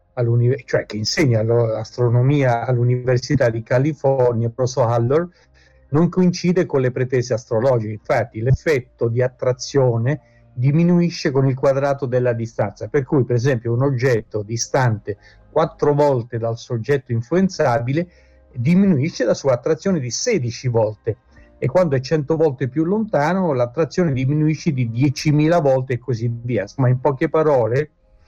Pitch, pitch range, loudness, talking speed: 130 Hz, 120-150 Hz, -19 LUFS, 135 wpm